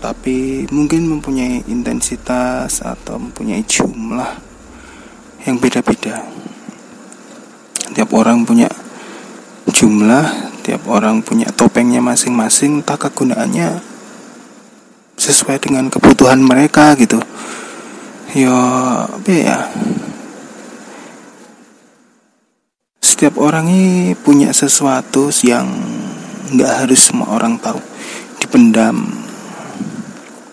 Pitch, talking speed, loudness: 205 Hz, 80 wpm, -12 LUFS